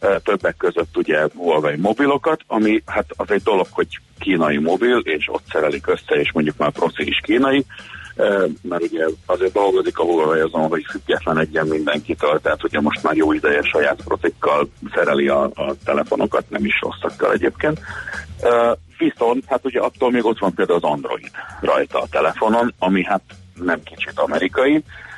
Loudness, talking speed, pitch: -19 LUFS, 160 wpm, 135 Hz